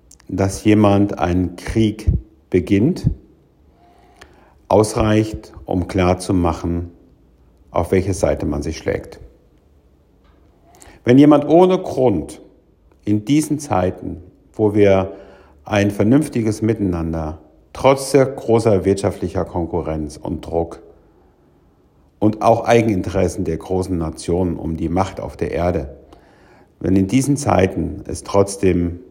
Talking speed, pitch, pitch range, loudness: 105 wpm, 95 Hz, 85-105 Hz, -18 LUFS